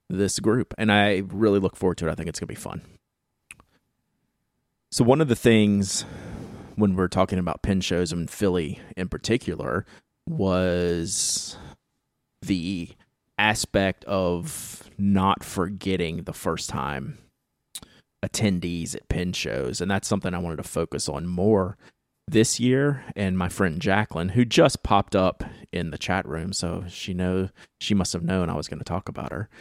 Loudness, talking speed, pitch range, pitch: -25 LUFS, 160 wpm, 90-105 Hz, 95 Hz